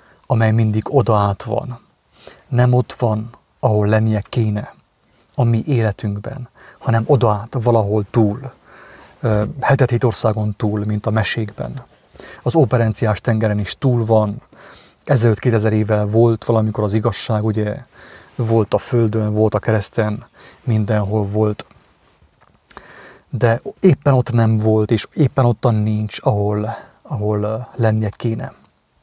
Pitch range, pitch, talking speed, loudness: 105-120 Hz, 110 Hz, 125 wpm, -17 LUFS